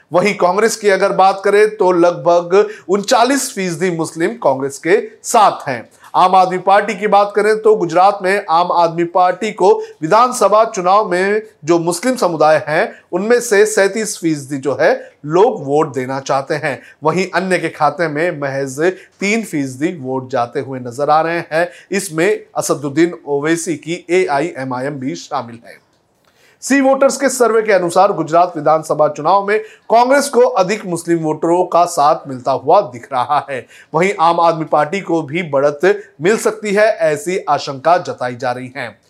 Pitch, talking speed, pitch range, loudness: 175 Hz, 165 wpm, 155-205 Hz, -14 LUFS